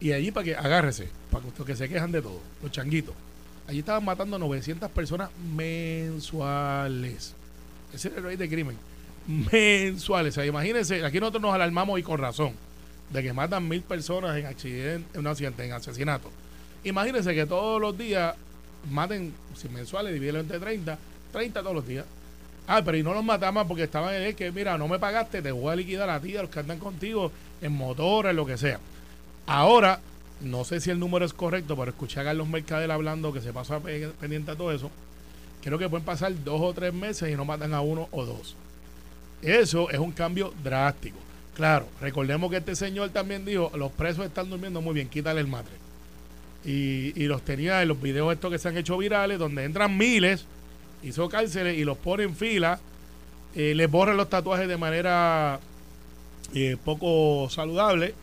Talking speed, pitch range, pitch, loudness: 190 wpm, 135-180 Hz, 155 Hz, -27 LUFS